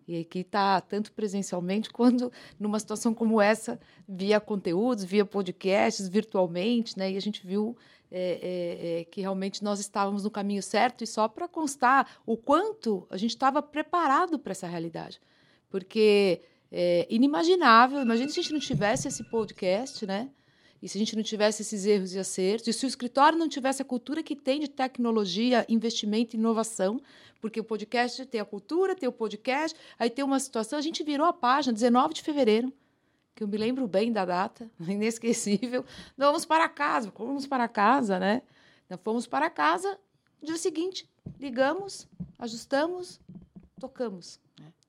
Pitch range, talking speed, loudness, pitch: 200-265 Hz, 165 wpm, -28 LUFS, 225 Hz